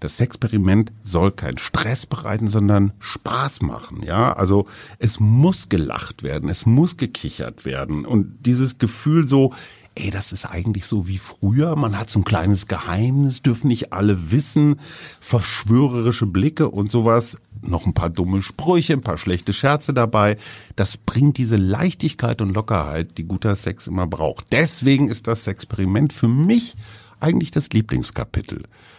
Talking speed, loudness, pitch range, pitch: 155 wpm, -20 LUFS, 100-135 Hz, 110 Hz